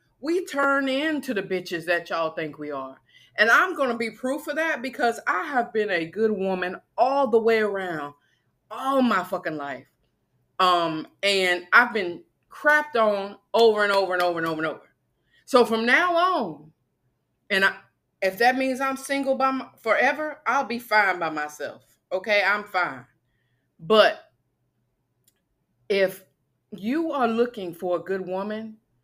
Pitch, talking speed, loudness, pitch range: 200 Hz, 160 wpm, -23 LUFS, 160-255 Hz